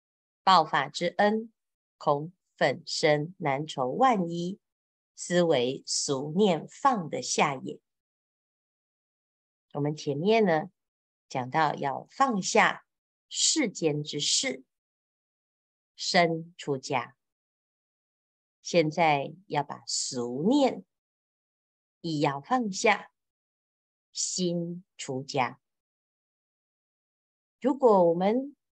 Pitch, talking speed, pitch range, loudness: 170 Hz, 110 characters per minute, 145-215 Hz, -27 LUFS